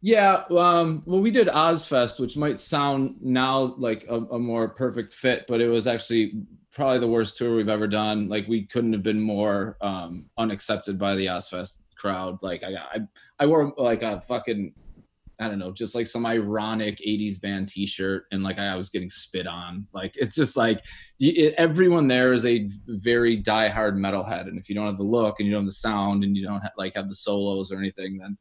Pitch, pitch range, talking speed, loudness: 110 Hz, 100-120 Hz, 210 wpm, -24 LUFS